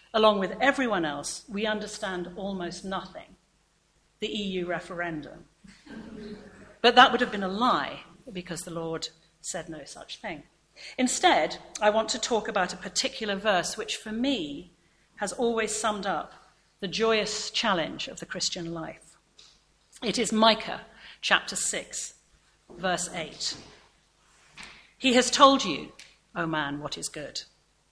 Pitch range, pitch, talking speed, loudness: 180-230 Hz, 210 Hz, 140 wpm, -27 LUFS